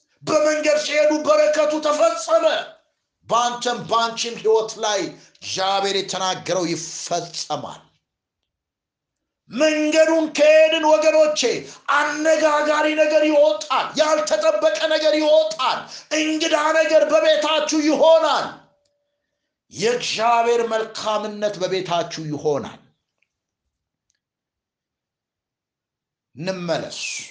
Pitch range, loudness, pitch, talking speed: 210-310 Hz, -19 LUFS, 300 Hz, 65 wpm